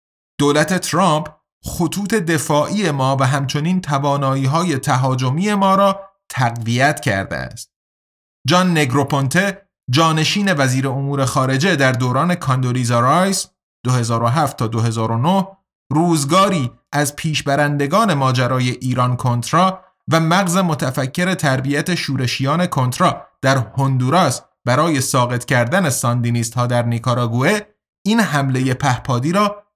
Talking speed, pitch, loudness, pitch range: 105 wpm, 145 Hz, -17 LUFS, 130-180 Hz